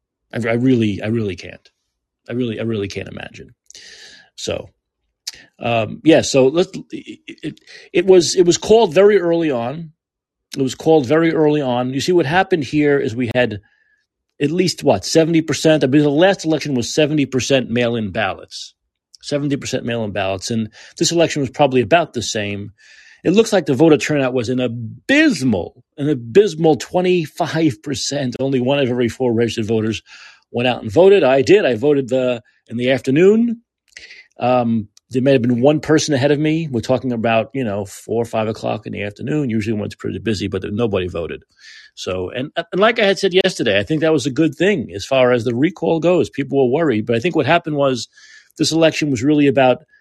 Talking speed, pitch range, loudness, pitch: 190 wpm, 115-160 Hz, -17 LUFS, 140 Hz